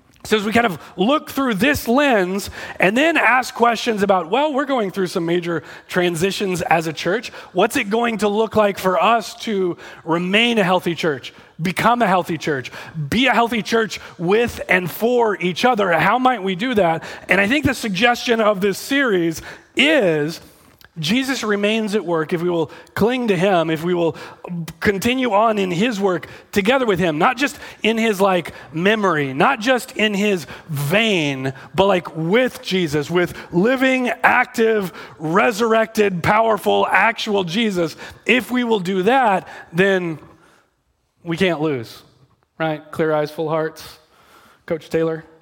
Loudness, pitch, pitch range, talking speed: -18 LUFS, 195 Hz, 170-230 Hz, 165 wpm